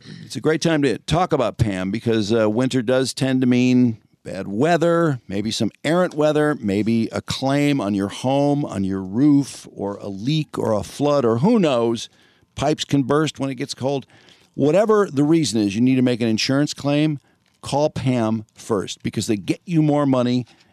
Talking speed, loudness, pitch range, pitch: 190 wpm, -20 LUFS, 115-150 Hz, 135 Hz